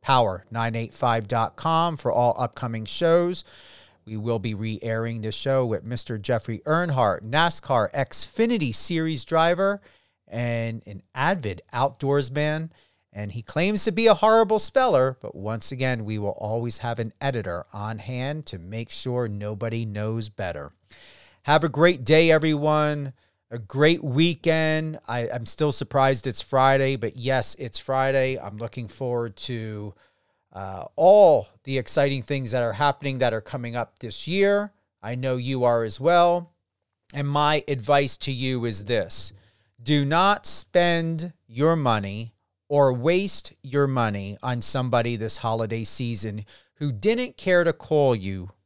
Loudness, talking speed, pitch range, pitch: -23 LUFS, 145 wpm, 115-150 Hz, 125 Hz